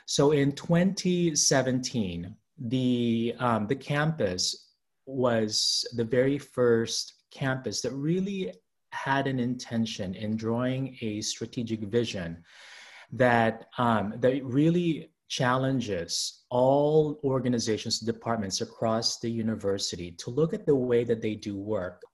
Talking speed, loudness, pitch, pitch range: 115 wpm, -28 LUFS, 120 Hz, 110-135 Hz